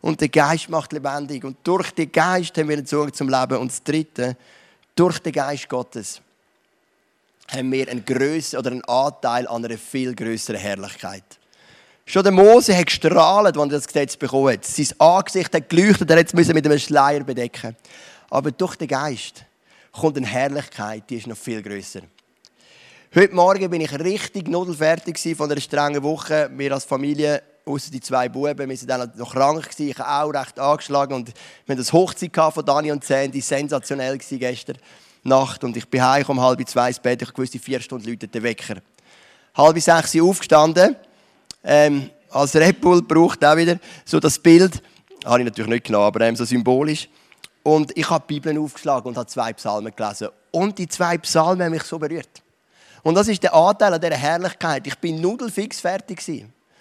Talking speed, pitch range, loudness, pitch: 190 wpm, 125-165 Hz, -19 LUFS, 145 Hz